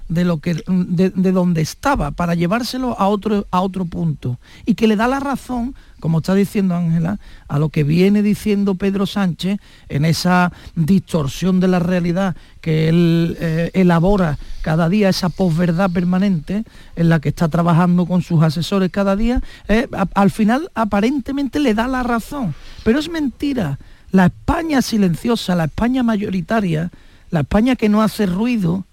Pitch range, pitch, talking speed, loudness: 170-215 Hz, 190 Hz, 165 wpm, -17 LUFS